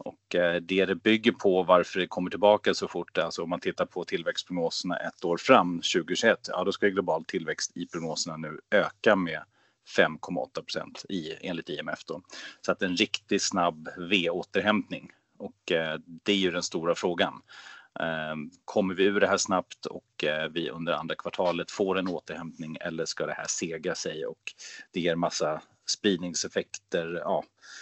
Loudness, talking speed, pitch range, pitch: -28 LUFS, 170 wpm, 85-95 Hz, 85 Hz